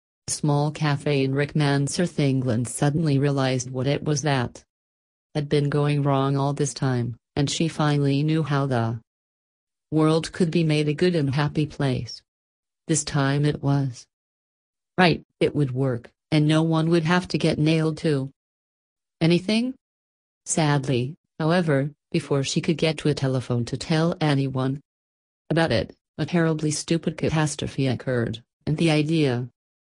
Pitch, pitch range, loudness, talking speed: 145 Hz, 130-155 Hz, -23 LUFS, 150 wpm